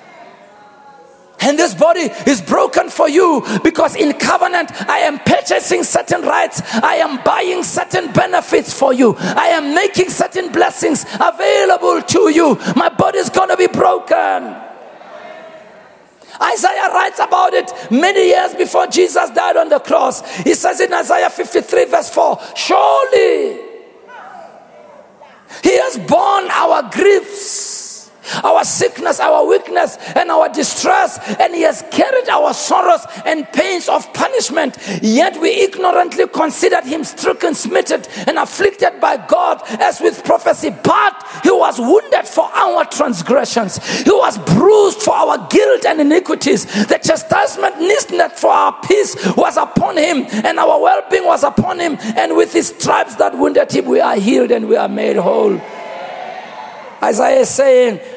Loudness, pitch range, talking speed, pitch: -13 LUFS, 305-400 Hz, 145 wpm, 345 Hz